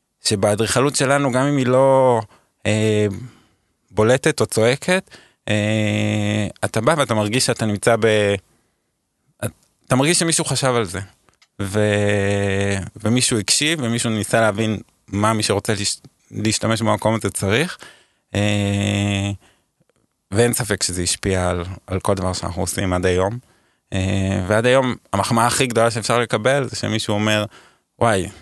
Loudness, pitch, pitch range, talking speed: -19 LUFS, 110 Hz, 100-120 Hz, 135 wpm